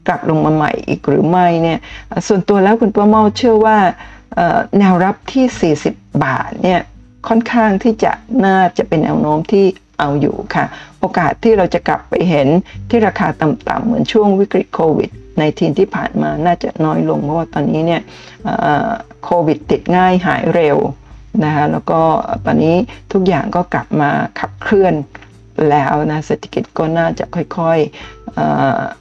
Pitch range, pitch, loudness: 150-205 Hz, 175 Hz, -14 LUFS